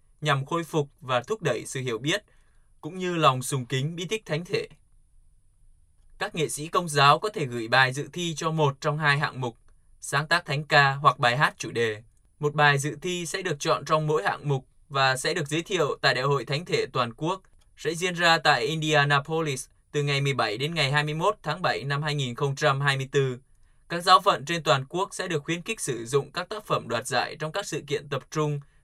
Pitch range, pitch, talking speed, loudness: 135-165 Hz, 150 Hz, 220 wpm, -25 LUFS